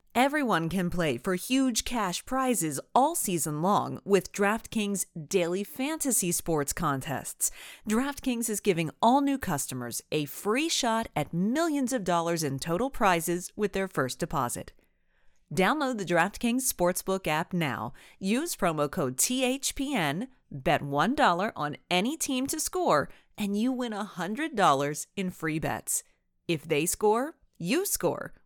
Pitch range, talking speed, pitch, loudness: 160-250 Hz, 135 wpm, 195 Hz, -28 LUFS